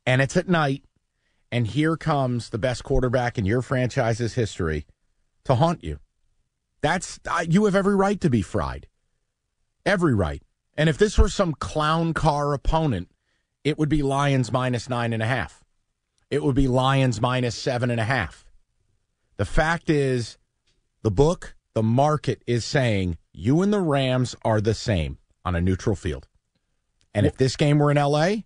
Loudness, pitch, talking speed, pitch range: -23 LUFS, 125 Hz, 170 wpm, 110-150 Hz